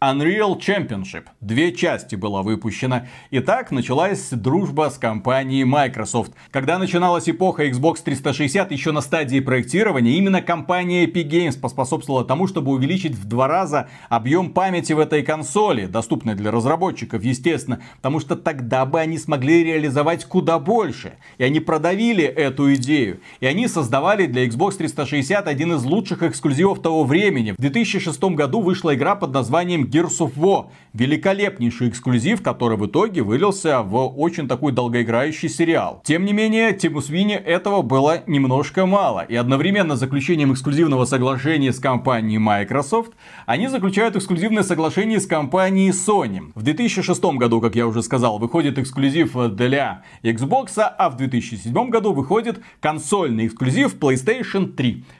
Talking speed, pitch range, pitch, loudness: 145 wpm, 130-180 Hz, 155 Hz, -19 LUFS